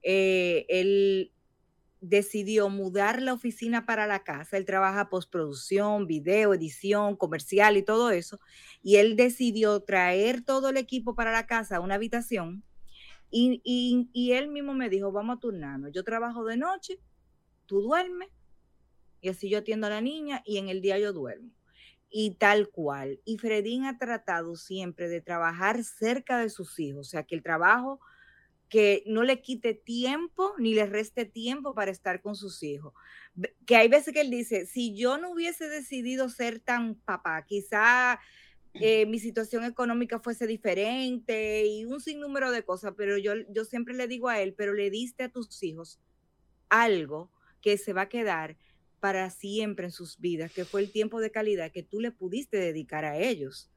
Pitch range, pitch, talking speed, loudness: 190-240 Hz, 215 Hz, 175 wpm, -28 LUFS